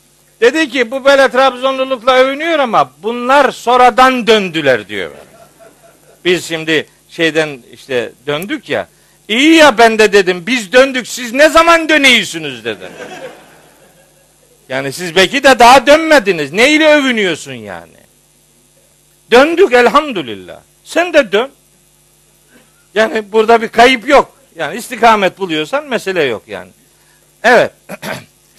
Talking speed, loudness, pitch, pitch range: 120 wpm, -10 LUFS, 240 Hz, 180-270 Hz